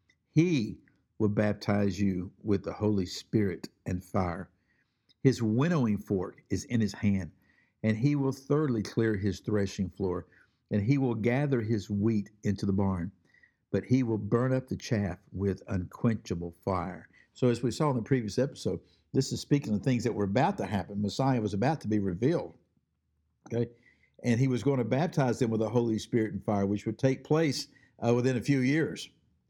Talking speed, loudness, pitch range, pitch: 185 wpm, -30 LUFS, 100-130 Hz, 110 Hz